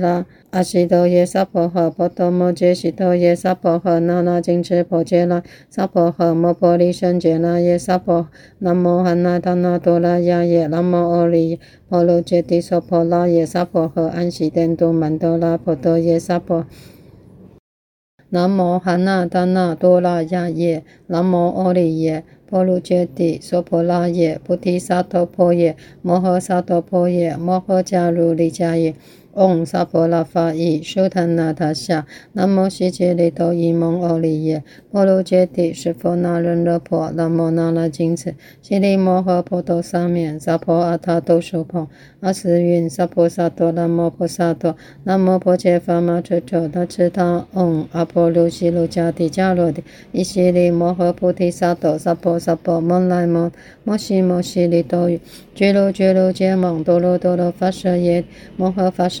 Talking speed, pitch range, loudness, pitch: 230 characters per minute, 170-180 Hz, -17 LUFS, 175 Hz